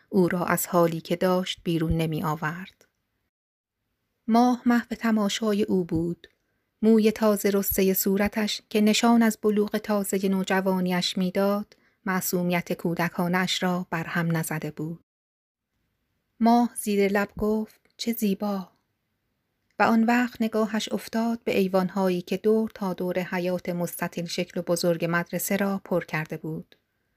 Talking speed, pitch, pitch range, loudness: 130 wpm, 190 Hz, 175-215 Hz, -25 LUFS